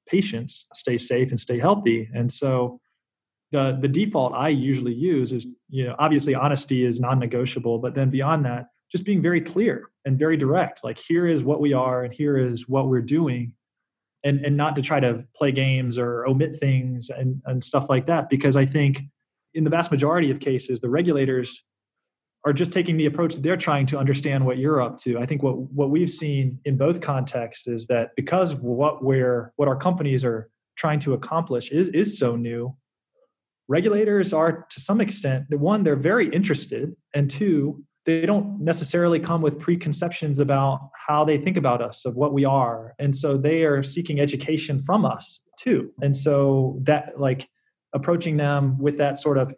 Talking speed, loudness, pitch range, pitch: 190 wpm, -23 LUFS, 130-160 Hz, 140 Hz